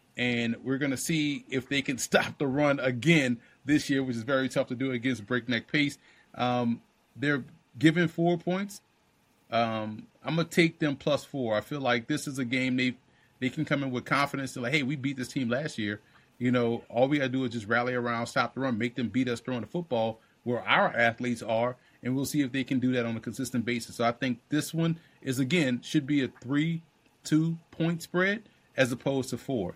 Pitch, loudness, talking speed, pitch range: 130 Hz, -29 LUFS, 225 wpm, 120-150 Hz